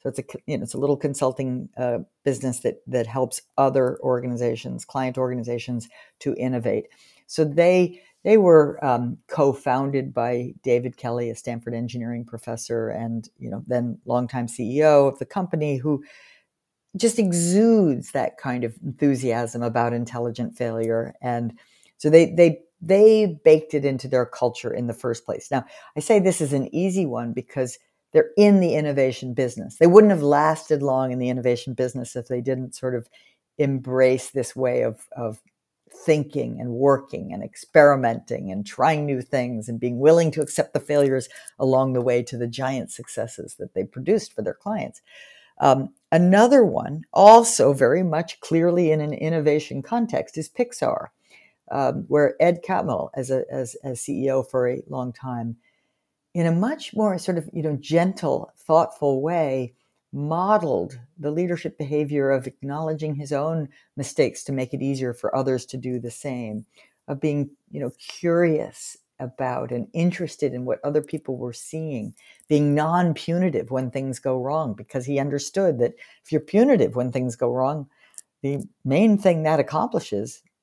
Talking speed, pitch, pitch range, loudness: 165 wpm, 140 Hz, 125-160 Hz, -22 LUFS